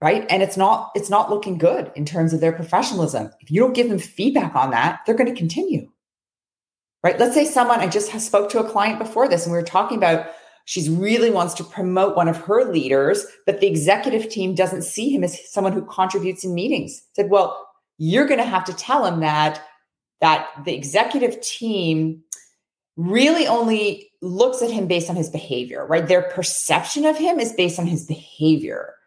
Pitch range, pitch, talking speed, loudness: 165-225 Hz, 185 Hz, 200 wpm, -20 LUFS